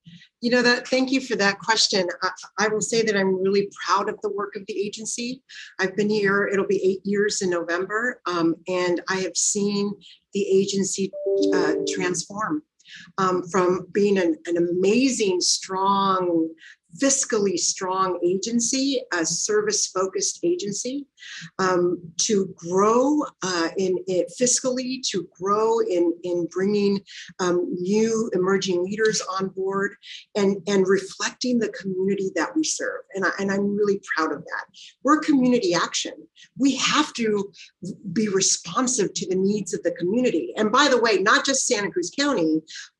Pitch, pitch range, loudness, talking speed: 200 Hz, 185-225 Hz, -23 LUFS, 155 wpm